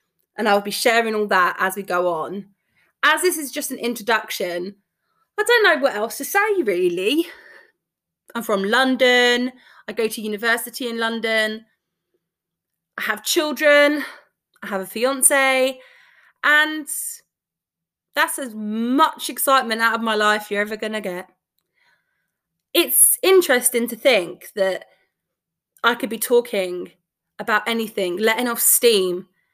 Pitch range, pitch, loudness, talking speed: 210-295 Hz, 235 Hz, -19 LUFS, 140 wpm